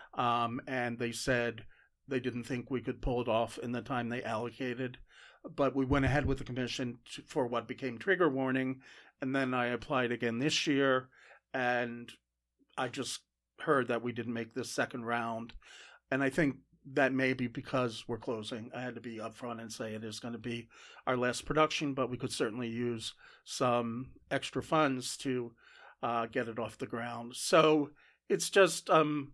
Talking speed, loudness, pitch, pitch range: 185 wpm, -34 LUFS, 125 Hz, 120-130 Hz